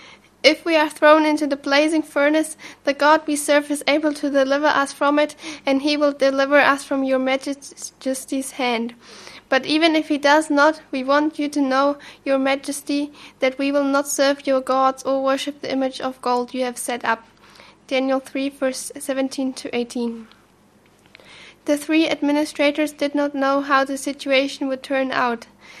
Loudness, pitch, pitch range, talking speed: -20 LUFS, 280 Hz, 265-295 Hz, 175 wpm